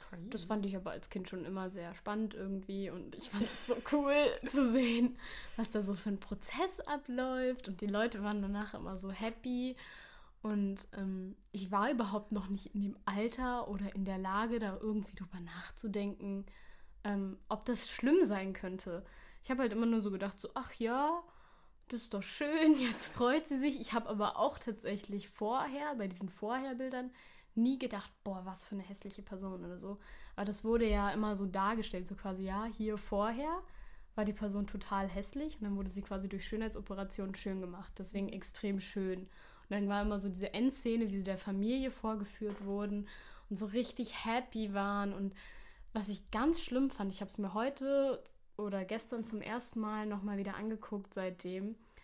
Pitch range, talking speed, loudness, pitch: 195-235 Hz, 185 wpm, -38 LUFS, 205 Hz